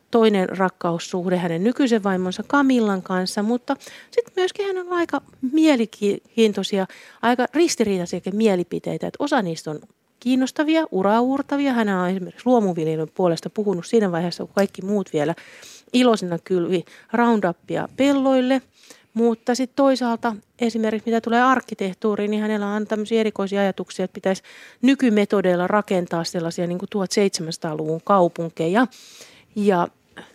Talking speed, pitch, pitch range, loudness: 125 wpm, 210 Hz, 185-245 Hz, -21 LUFS